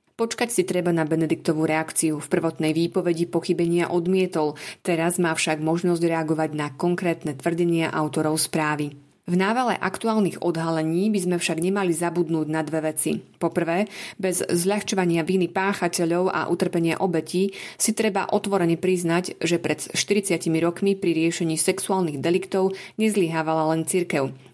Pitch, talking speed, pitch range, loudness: 170 Hz, 135 wpm, 160-185 Hz, -23 LUFS